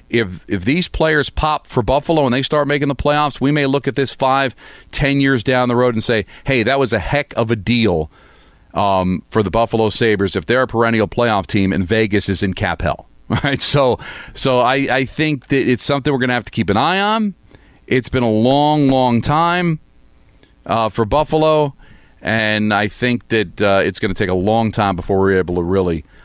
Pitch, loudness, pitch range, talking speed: 120 Hz, -16 LUFS, 105-140 Hz, 215 wpm